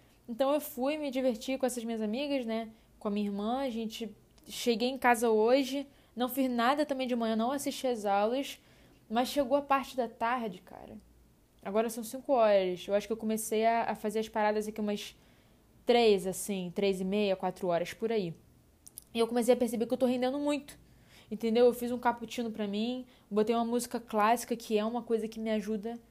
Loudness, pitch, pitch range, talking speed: -31 LUFS, 230 Hz, 215-255 Hz, 205 wpm